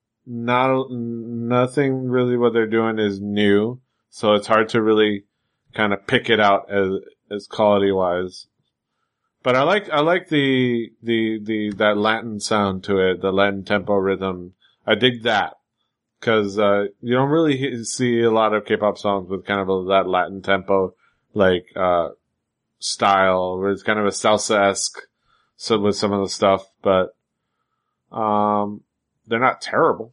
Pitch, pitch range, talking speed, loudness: 105 Hz, 100-115 Hz, 160 wpm, -20 LUFS